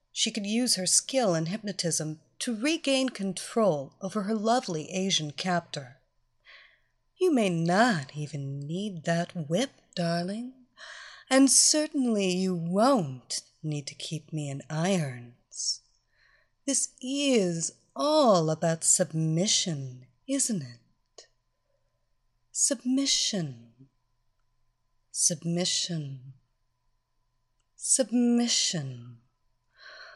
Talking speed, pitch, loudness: 85 wpm, 170 Hz, -27 LUFS